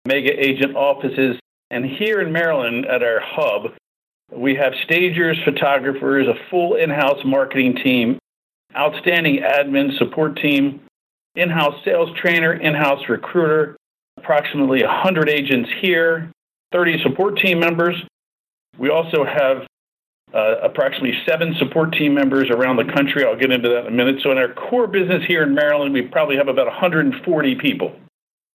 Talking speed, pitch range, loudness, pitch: 150 wpm, 135-170 Hz, -17 LUFS, 150 Hz